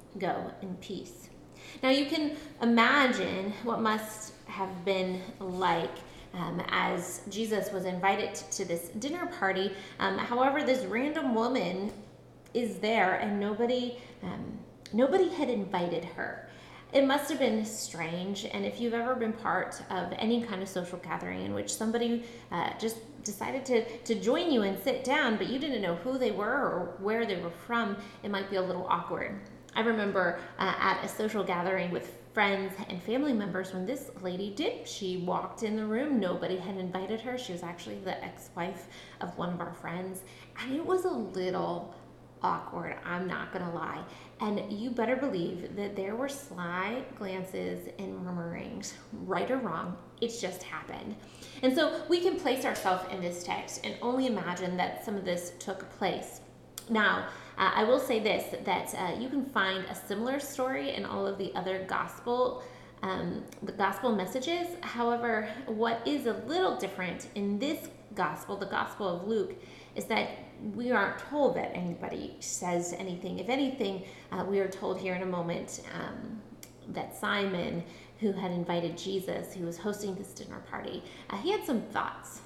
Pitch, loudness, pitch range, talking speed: 205 Hz, -32 LUFS, 185-245 Hz, 170 wpm